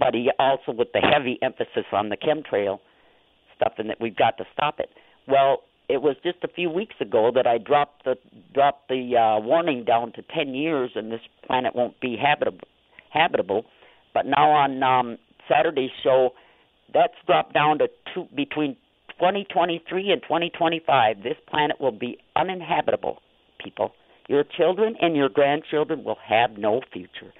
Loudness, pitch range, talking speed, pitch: -23 LUFS, 130-170 Hz, 160 wpm, 145 Hz